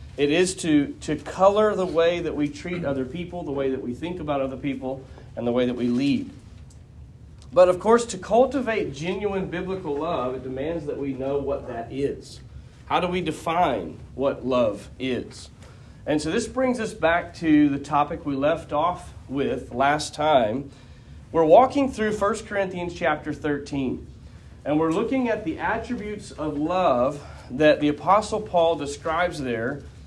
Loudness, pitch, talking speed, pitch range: -24 LUFS, 155 Hz, 170 wpm, 140-185 Hz